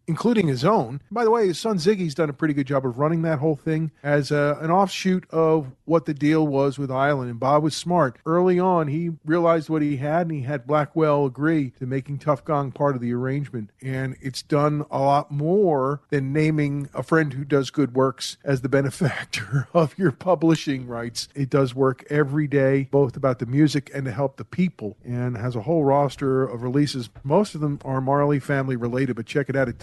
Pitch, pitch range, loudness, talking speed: 145 Hz, 135-160 Hz, -23 LUFS, 215 wpm